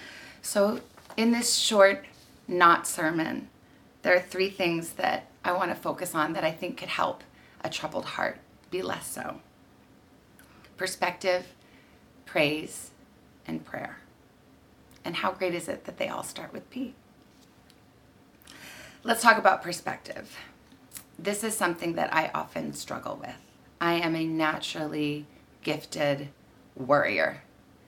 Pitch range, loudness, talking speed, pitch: 155-205 Hz, -28 LUFS, 130 wpm, 180 Hz